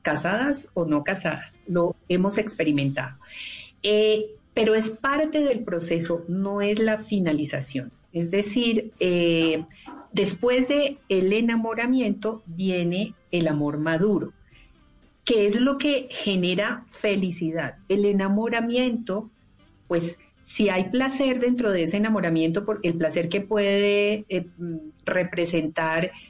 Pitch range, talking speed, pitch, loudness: 170-220 Hz, 115 wpm, 195 Hz, -24 LUFS